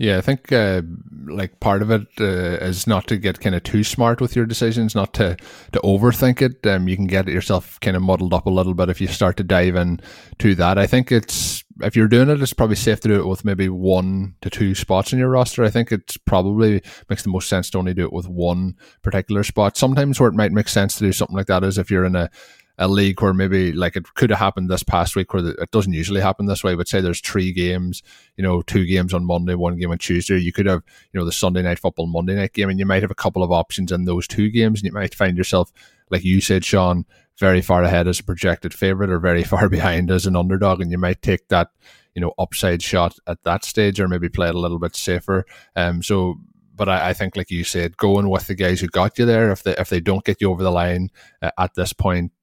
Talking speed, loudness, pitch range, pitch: 265 wpm, -19 LUFS, 90-105 Hz, 95 Hz